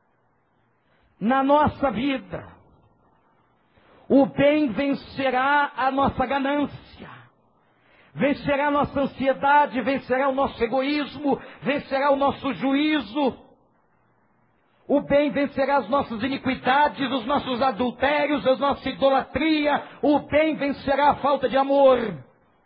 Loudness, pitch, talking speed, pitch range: -22 LUFS, 275 Hz, 105 wpm, 265-285 Hz